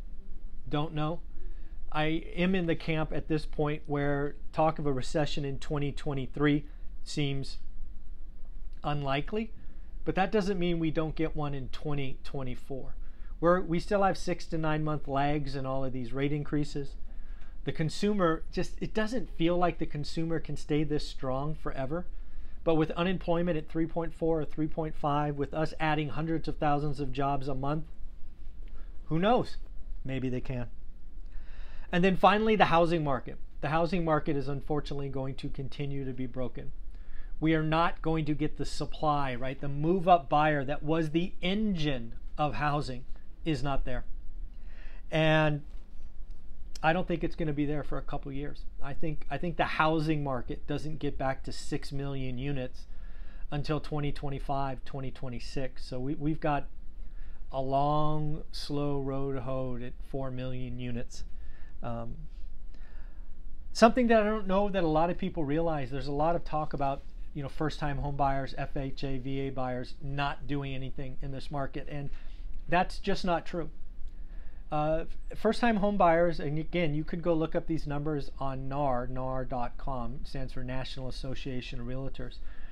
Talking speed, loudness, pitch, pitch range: 160 wpm, -32 LUFS, 145 Hz, 130-160 Hz